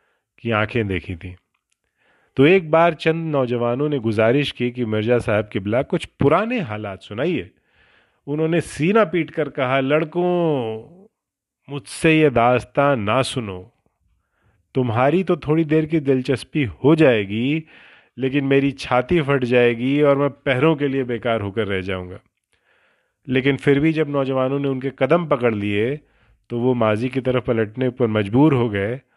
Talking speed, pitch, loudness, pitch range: 165 wpm, 130 Hz, -19 LUFS, 115-150 Hz